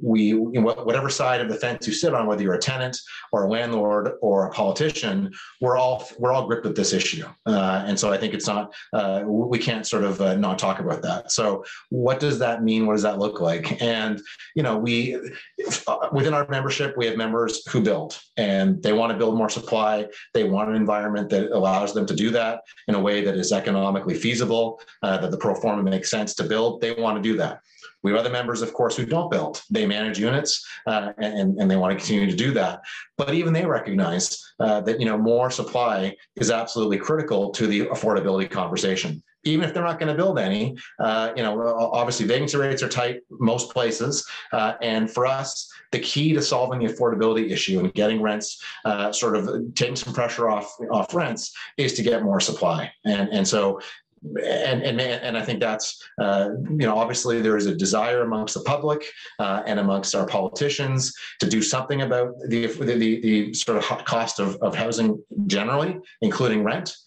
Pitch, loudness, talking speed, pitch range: 115 Hz, -23 LUFS, 205 wpm, 105-135 Hz